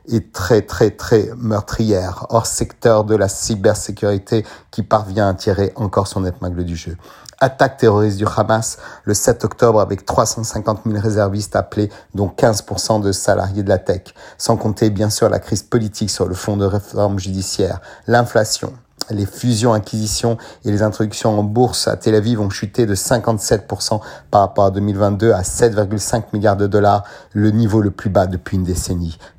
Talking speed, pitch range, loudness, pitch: 170 wpm, 100-115 Hz, -17 LUFS, 105 Hz